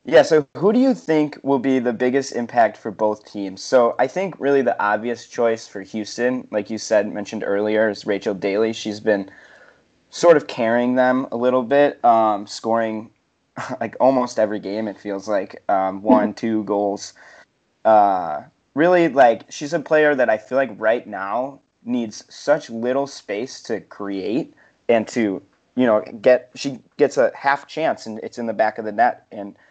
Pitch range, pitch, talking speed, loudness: 105-135 Hz, 115 Hz, 180 wpm, -20 LUFS